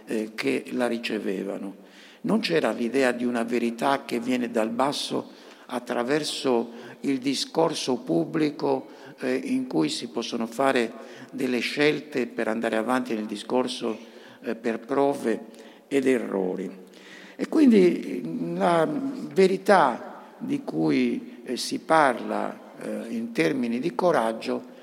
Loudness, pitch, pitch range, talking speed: -25 LUFS, 125 Hz, 115-150 Hz, 110 wpm